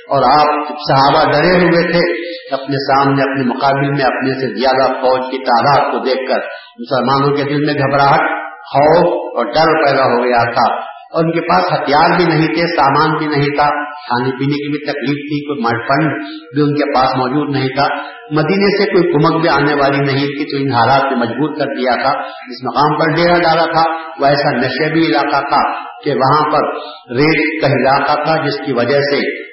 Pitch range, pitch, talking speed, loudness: 135-160 Hz, 145 Hz, 195 wpm, -13 LUFS